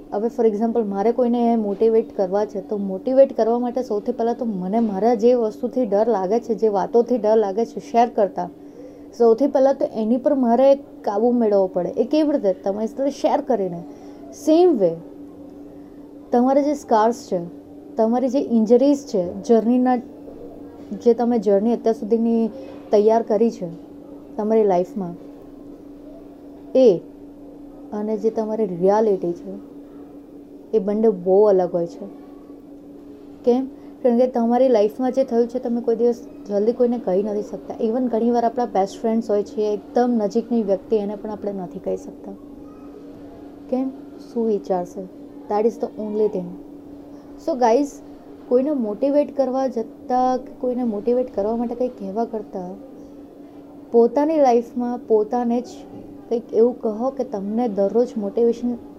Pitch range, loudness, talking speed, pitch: 215-265 Hz, -20 LUFS, 140 wpm, 235 Hz